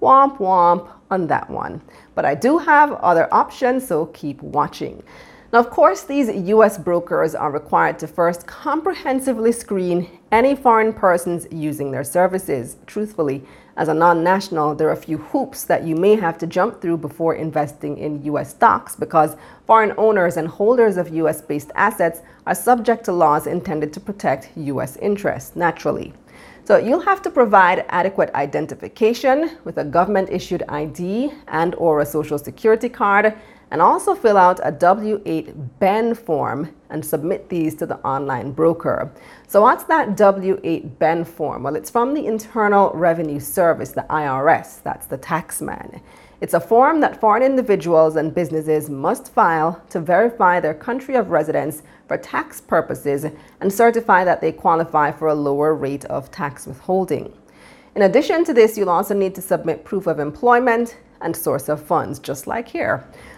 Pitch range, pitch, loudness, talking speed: 155-225 Hz, 180 Hz, -18 LUFS, 170 wpm